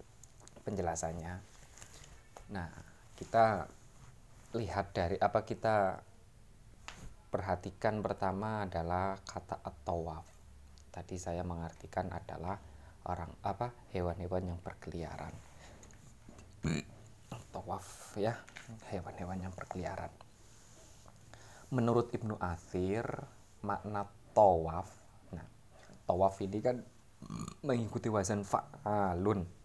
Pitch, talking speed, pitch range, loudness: 100 Hz, 75 wpm, 90-115 Hz, -37 LUFS